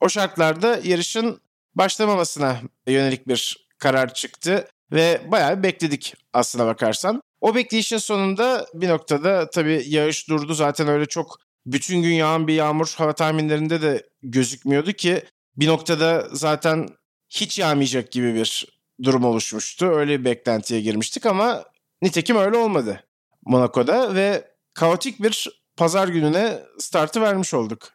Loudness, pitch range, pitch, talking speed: -21 LUFS, 135-190 Hz, 160 Hz, 130 wpm